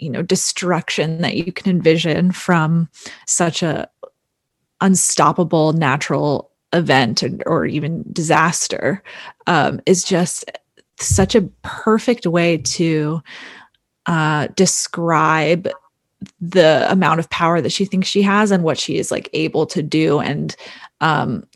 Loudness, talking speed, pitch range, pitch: -17 LUFS, 130 wpm, 155-185 Hz, 170 Hz